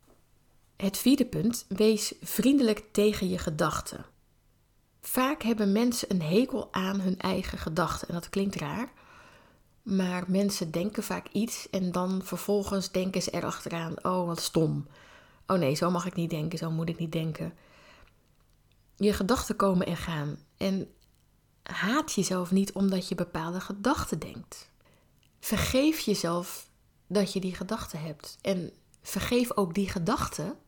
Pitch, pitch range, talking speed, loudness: 190 Hz, 175-210 Hz, 145 wpm, -29 LUFS